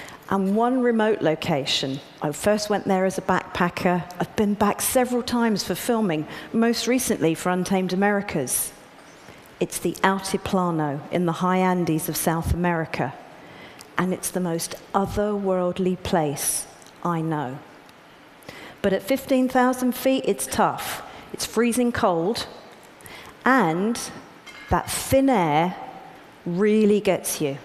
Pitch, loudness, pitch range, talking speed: 190 Hz, -23 LUFS, 170-215 Hz, 125 wpm